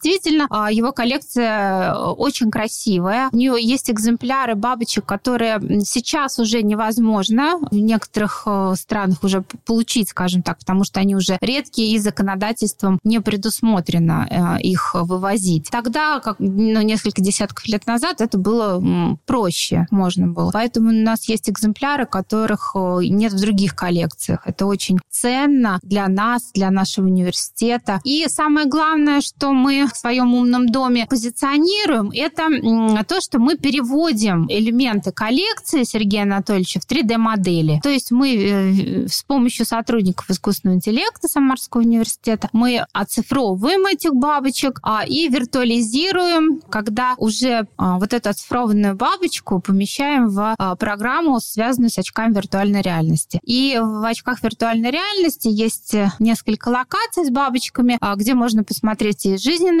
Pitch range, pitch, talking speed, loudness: 200-255 Hz, 225 Hz, 130 wpm, -18 LUFS